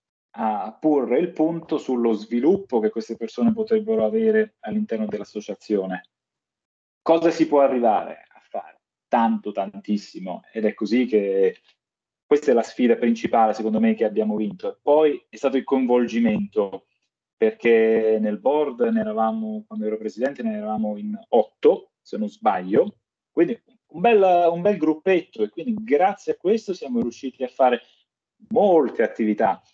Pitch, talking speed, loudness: 130 Hz, 145 wpm, -22 LUFS